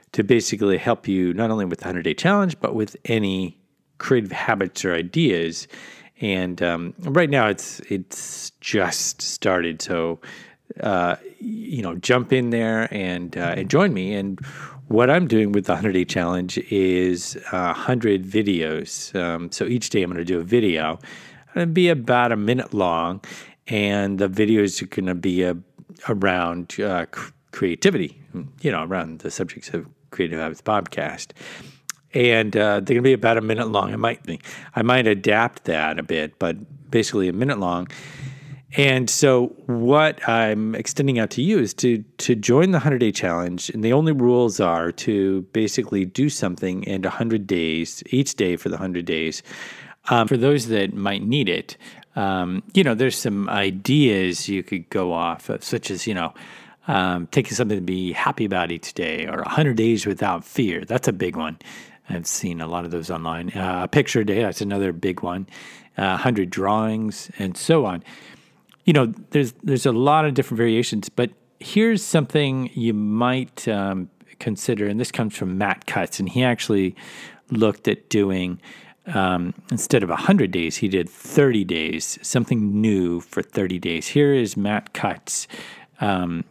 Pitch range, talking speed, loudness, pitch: 95-125 Hz, 175 wpm, -21 LUFS, 105 Hz